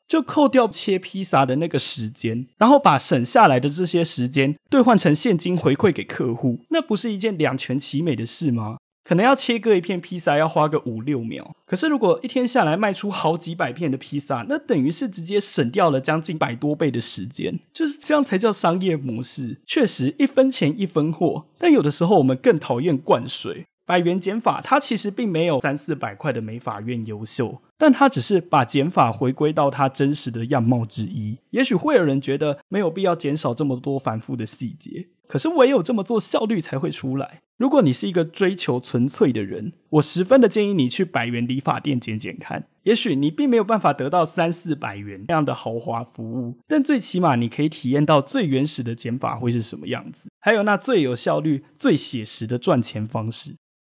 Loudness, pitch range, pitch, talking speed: -21 LUFS, 130-200 Hz, 155 Hz, 315 characters per minute